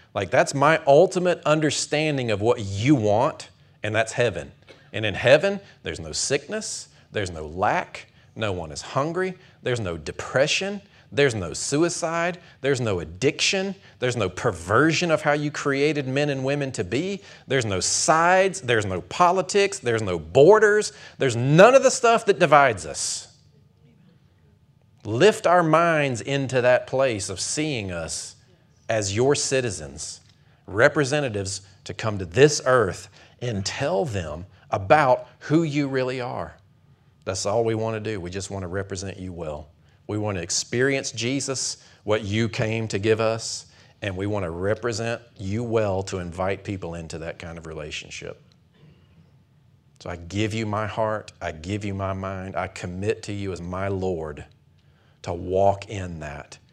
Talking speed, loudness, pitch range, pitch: 160 wpm, -23 LUFS, 95-145 Hz, 115 Hz